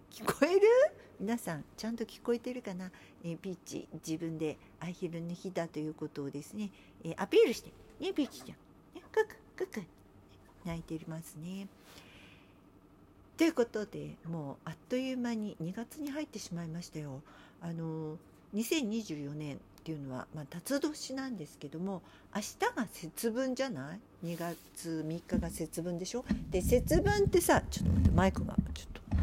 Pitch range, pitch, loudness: 155-230 Hz, 170 Hz, -35 LUFS